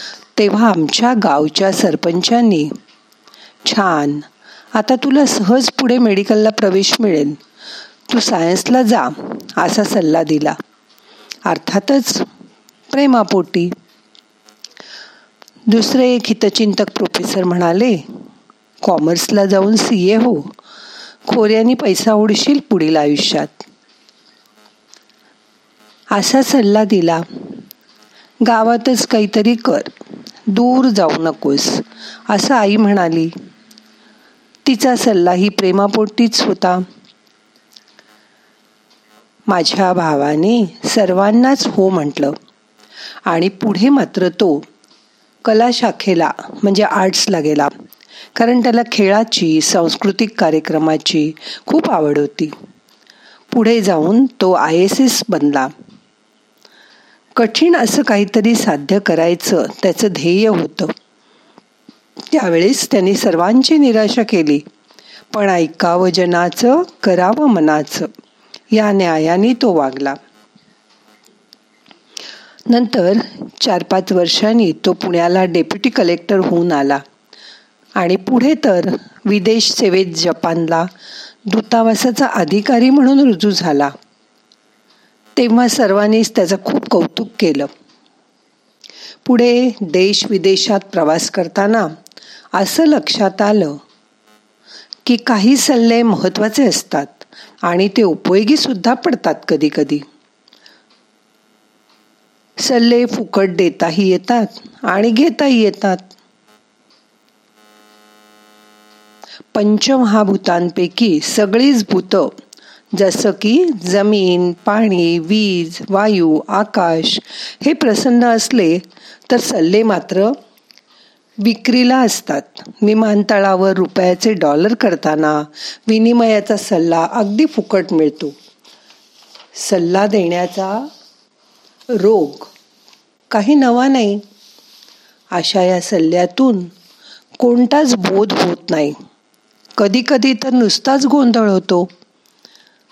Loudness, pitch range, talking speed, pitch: -13 LUFS, 170-235 Hz, 85 wpm, 205 Hz